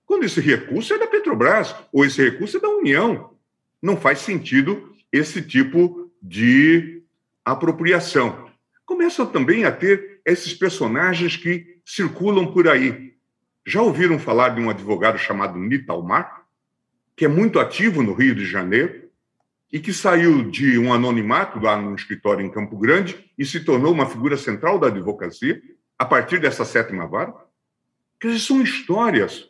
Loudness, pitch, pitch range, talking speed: -19 LUFS, 175 Hz, 140-205 Hz, 150 wpm